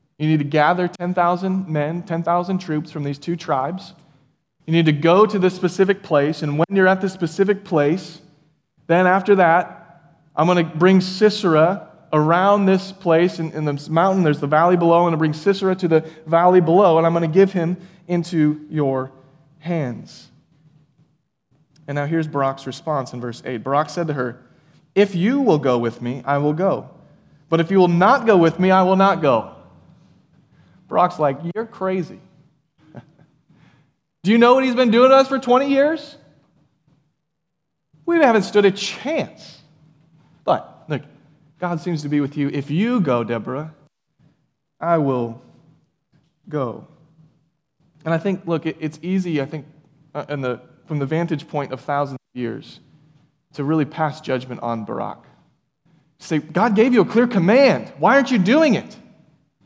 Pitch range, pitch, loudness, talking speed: 150-185 Hz, 160 Hz, -19 LUFS, 170 wpm